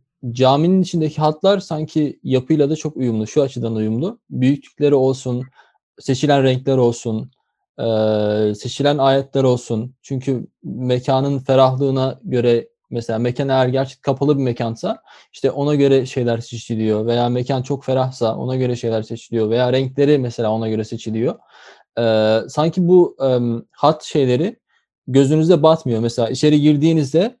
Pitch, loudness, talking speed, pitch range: 130 Hz, -18 LUFS, 125 wpm, 120-145 Hz